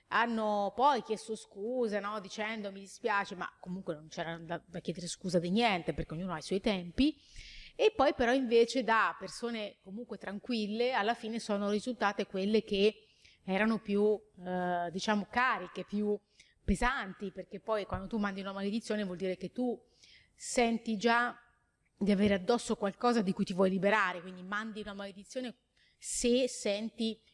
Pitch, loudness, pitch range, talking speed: 210 Hz, -33 LUFS, 190-230 Hz, 160 wpm